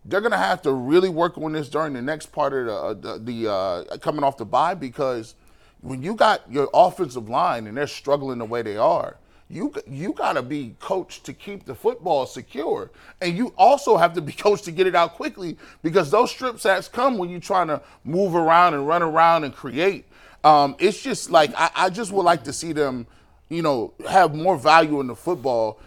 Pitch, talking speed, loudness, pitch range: 165 Hz, 215 wpm, -21 LUFS, 140-185 Hz